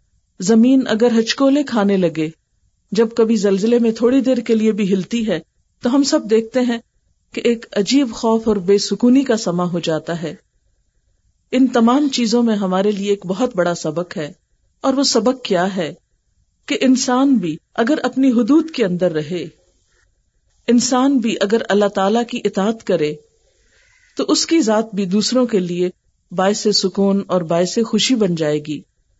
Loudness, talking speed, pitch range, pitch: -17 LUFS, 170 wpm, 185-245 Hz, 220 Hz